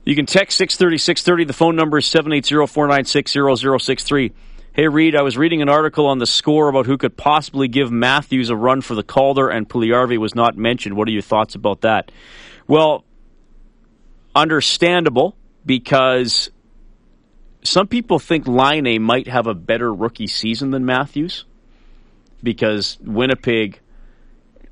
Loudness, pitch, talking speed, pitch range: -16 LUFS, 135 Hz, 170 wpm, 120-150 Hz